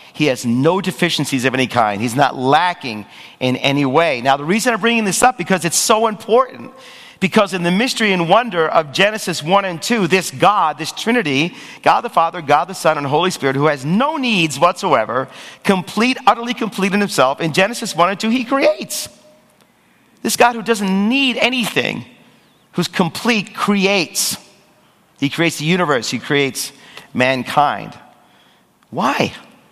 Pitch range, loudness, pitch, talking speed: 150-225 Hz, -16 LUFS, 185 Hz, 165 wpm